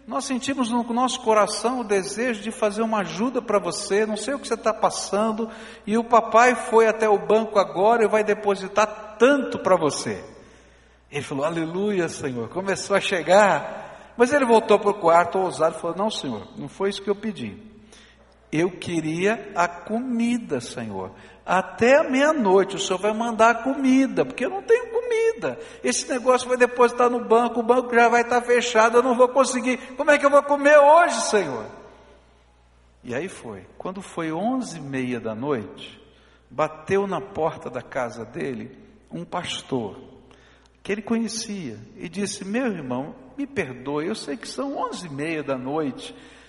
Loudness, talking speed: -22 LUFS, 175 wpm